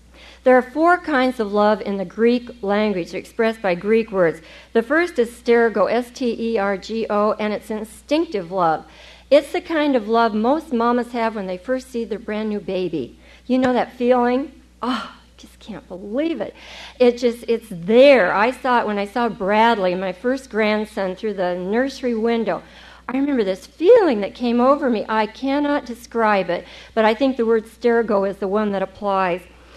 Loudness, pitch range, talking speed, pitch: -19 LUFS, 205-255 Hz, 180 wpm, 230 Hz